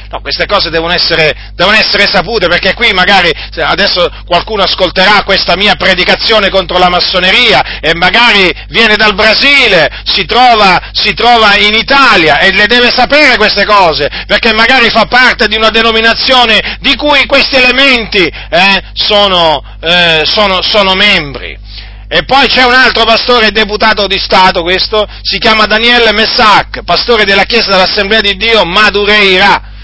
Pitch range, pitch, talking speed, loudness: 185-230 Hz, 210 Hz, 150 wpm, -5 LUFS